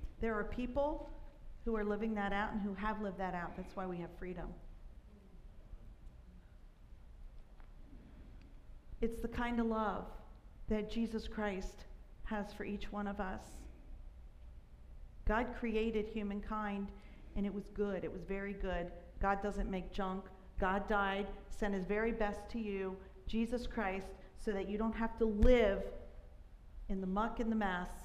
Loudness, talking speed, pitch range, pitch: -39 LUFS, 150 wpm, 185-220 Hz, 200 Hz